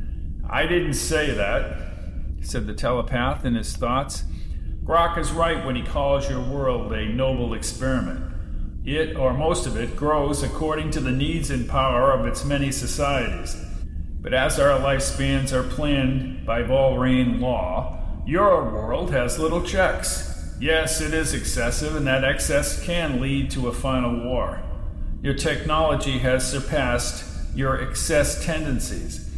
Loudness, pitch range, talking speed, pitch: -23 LUFS, 85-145 Hz, 145 wpm, 130 Hz